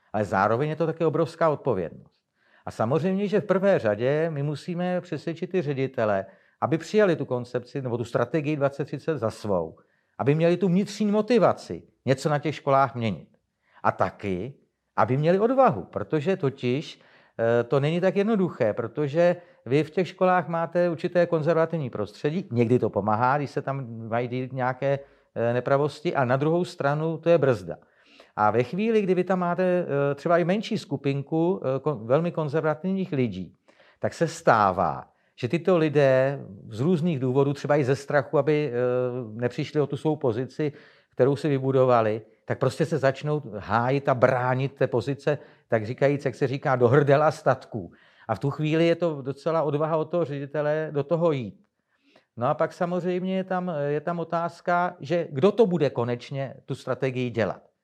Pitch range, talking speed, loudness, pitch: 125-170 Hz, 165 wpm, -25 LUFS, 145 Hz